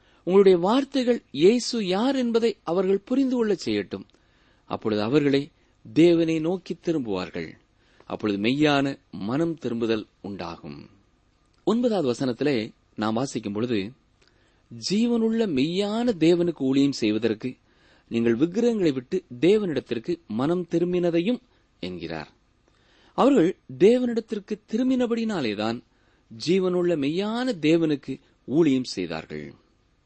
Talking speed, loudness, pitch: 90 wpm, -24 LUFS, 160 Hz